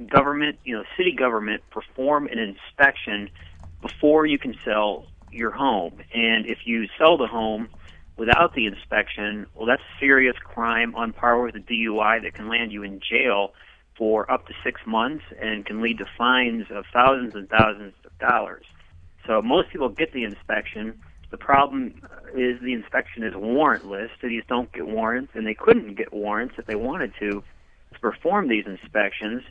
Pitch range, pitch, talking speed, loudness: 100-120 Hz, 110 Hz, 170 wpm, -23 LUFS